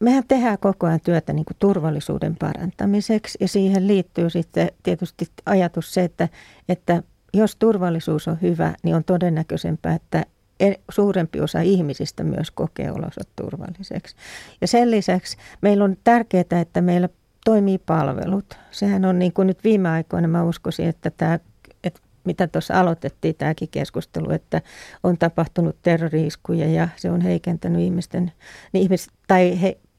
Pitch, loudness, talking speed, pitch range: 180 Hz, -21 LUFS, 145 wpm, 165-195 Hz